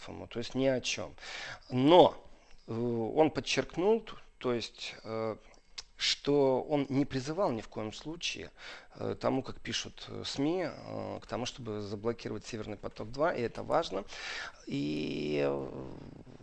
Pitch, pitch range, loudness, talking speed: 115 Hz, 105-135 Hz, -33 LUFS, 135 wpm